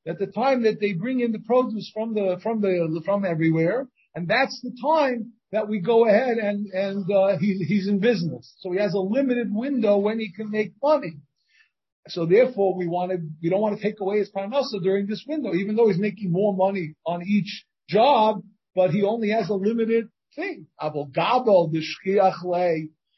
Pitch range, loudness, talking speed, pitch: 185-225 Hz, -23 LUFS, 195 wpm, 205 Hz